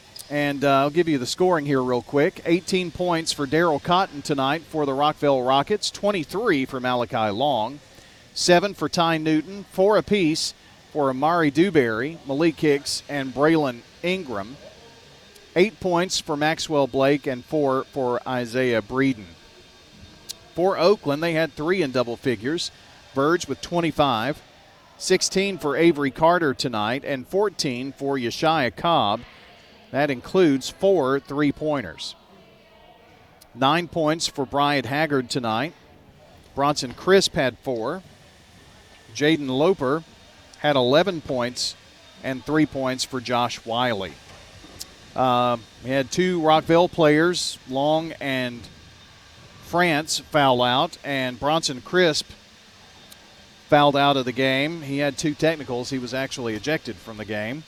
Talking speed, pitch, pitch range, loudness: 130 wpm, 140 Hz, 130-160 Hz, -22 LUFS